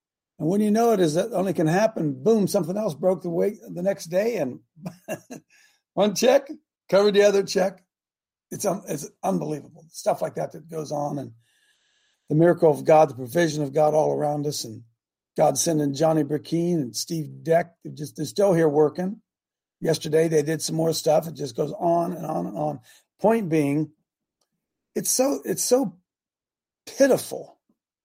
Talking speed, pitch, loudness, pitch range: 175 wpm, 165 Hz, -23 LUFS, 155-195 Hz